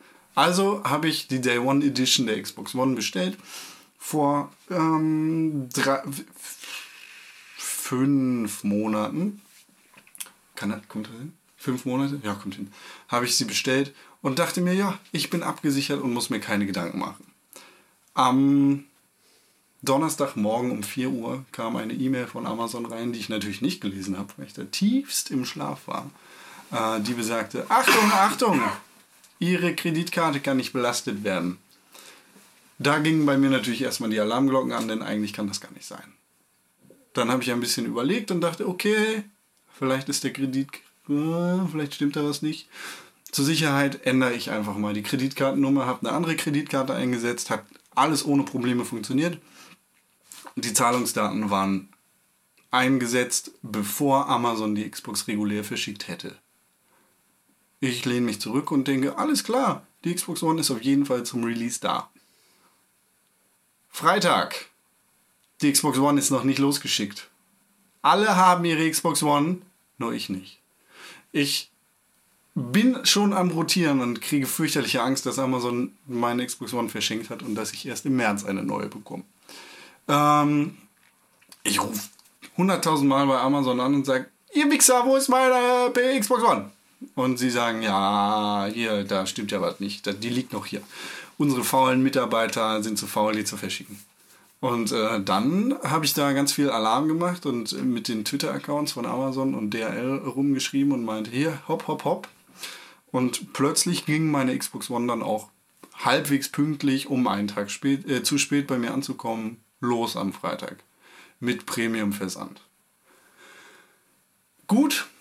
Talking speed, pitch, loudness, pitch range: 150 wpm, 135 Hz, -24 LUFS, 115-155 Hz